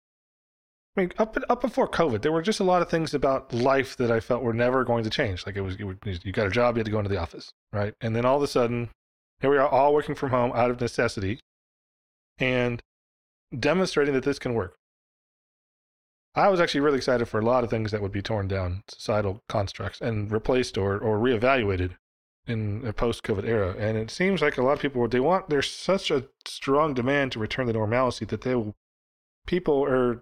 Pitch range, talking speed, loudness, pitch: 105-135 Hz, 220 wpm, -25 LUFS, 120 Hz